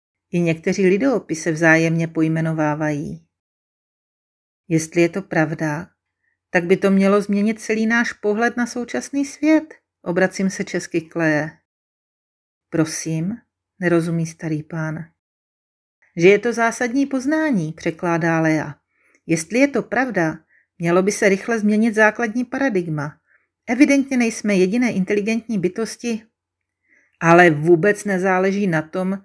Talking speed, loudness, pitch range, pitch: 115 wpm, -19 LUFS, 165-225 Hz, 185 Hz